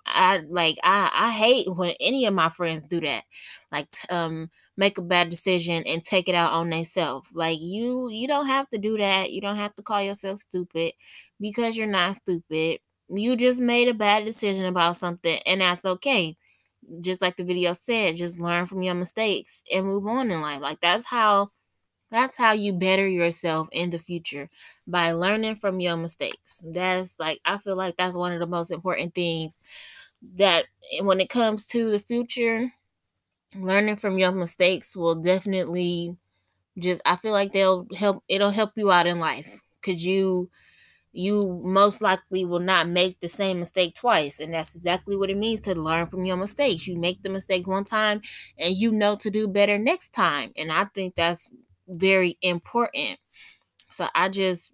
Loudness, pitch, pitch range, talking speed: -21 LUFS, 185 Hz, 175-205 Hz, 185 wpm